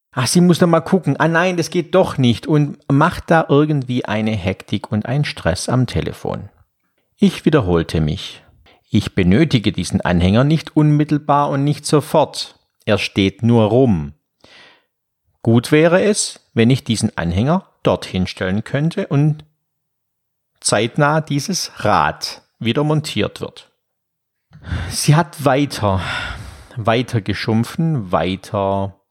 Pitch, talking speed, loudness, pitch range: 130 Hz, 130 wpm, -17 LUFS, 105-155 Hz